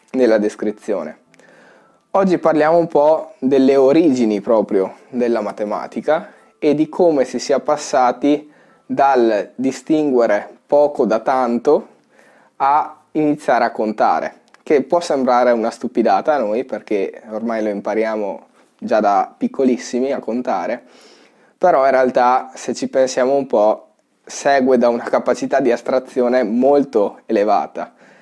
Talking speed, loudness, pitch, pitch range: 125 wpm, -17 LUFS, 130 Hz, 120-150 Hz